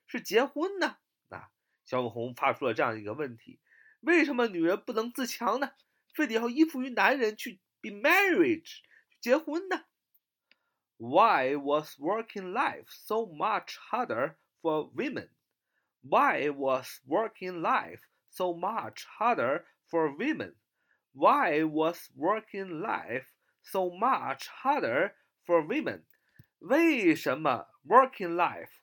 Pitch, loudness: 220 Hz, -29 LUFS